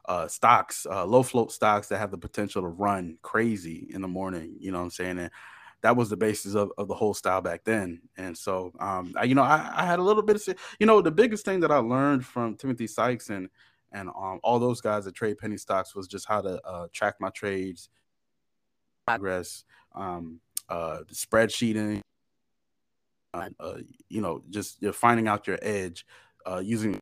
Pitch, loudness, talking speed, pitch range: 105 Hz, -27 LUFS, 200 wpm, 95-120 Hz